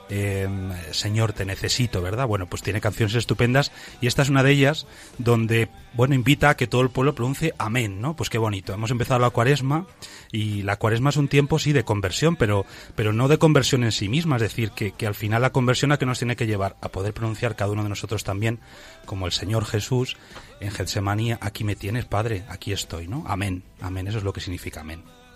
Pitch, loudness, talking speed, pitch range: 110 Hz, -23 LUFS, 220 wpm, 100-125 Hz